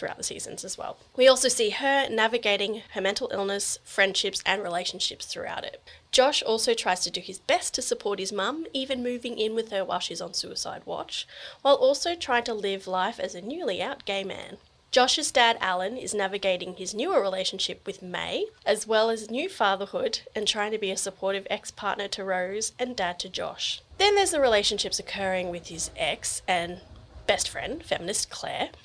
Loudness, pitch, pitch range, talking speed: -26 LUFS, 205 Hz, 190-245 Hz, 195 wpm